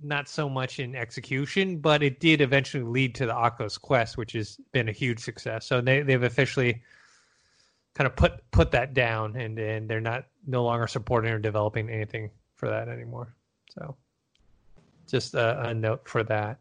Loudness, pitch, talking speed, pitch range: -27 LUFS, 120 Hz, 180 wpm, 115-135 Hz